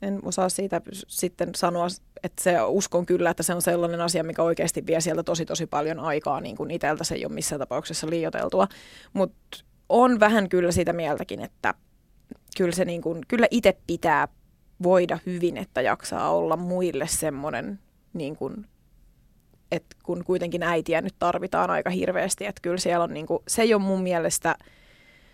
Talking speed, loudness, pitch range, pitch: 170 wpm, -25 LUFS, 170-185 Hz, 175 Hz